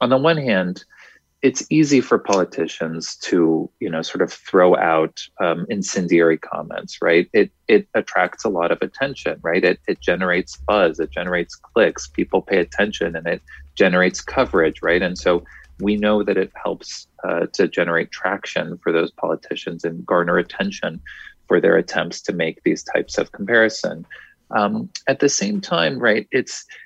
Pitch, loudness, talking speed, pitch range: 105 Hz, -20 LUFS, 170 wpm, 85-140 Hz